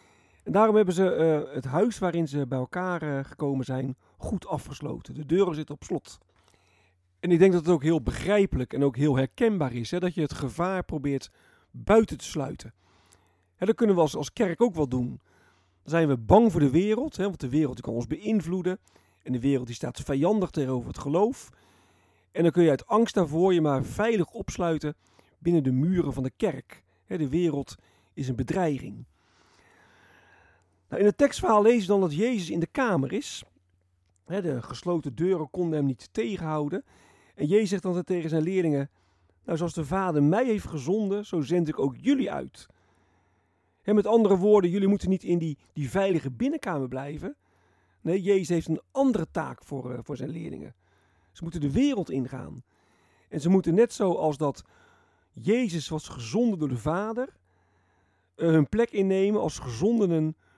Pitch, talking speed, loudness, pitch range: 155 Hz, 180 wpm, -26 LUFS, 130-190 Hz